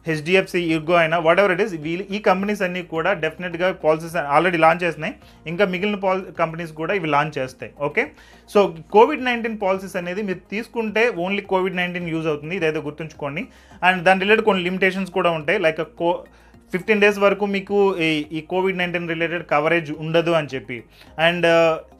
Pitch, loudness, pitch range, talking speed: 180 Hz, -20 LUFS, 160-195 Hz, 170 wpm